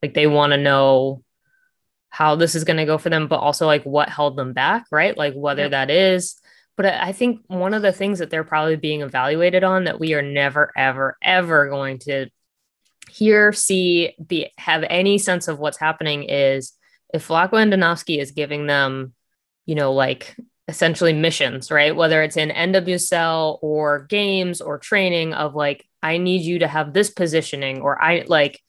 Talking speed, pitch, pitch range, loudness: 185 wpm, 160 Hz, 145-180 Hz, -19 LUFS